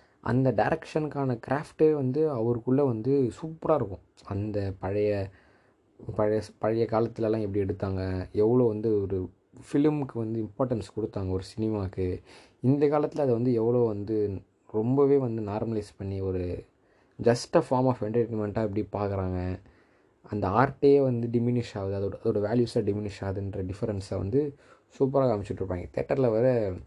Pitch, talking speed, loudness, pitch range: 110 Hz, 125 wpm, -28 LUFS, 100-130 Hz